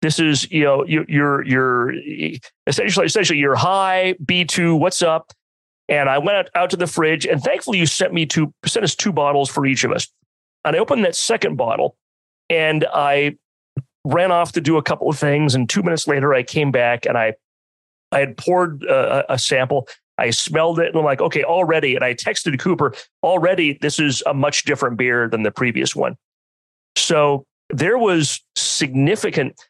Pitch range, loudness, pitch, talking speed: 130-165 Hz, -18 LUFS, 145 Hz, 190 wpm